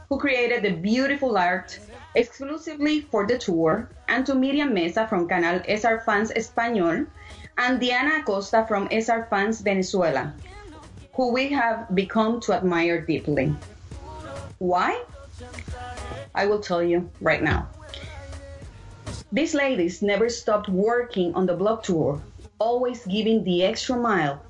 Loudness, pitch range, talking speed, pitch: -23 LUFS, 170-240 Hz, 130 wpm, 205 Hz